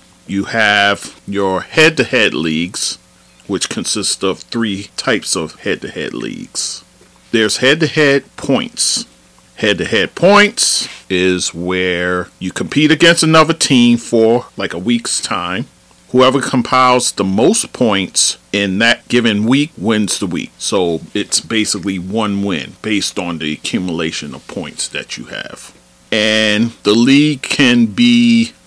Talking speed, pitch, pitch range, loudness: 145 wpm, 105 Hz, 90-130 Hz, -14 LUFS